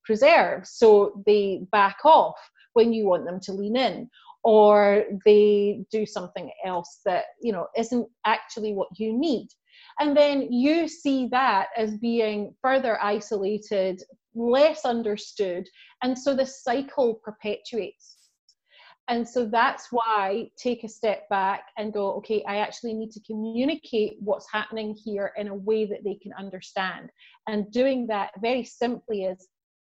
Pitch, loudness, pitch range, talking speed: 220 Hz, -24 LUFS, 205-245 Hz, 145 wpm